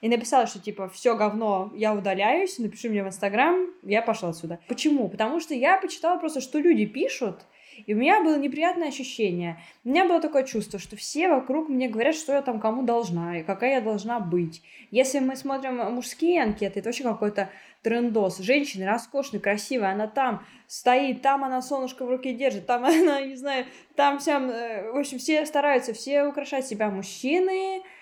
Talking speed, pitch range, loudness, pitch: 180 wpm, 210-285 Hz, -25 LUFS, 250 Hz